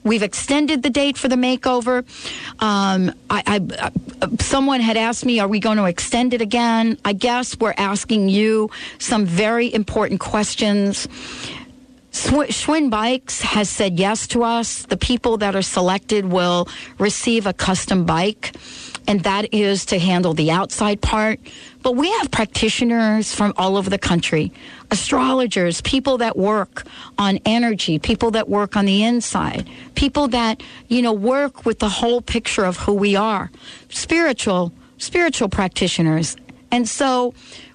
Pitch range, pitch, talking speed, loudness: 200-245 Hz, 220 Hz, 150 wpm, -19 LUFS